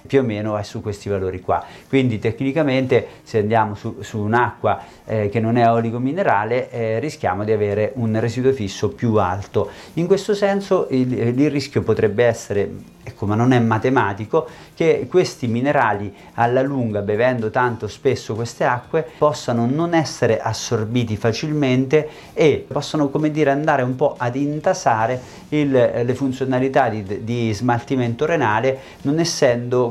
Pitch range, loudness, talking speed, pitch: 110-140 Hz, -20 LUFS, 150 wpm, 125 Hz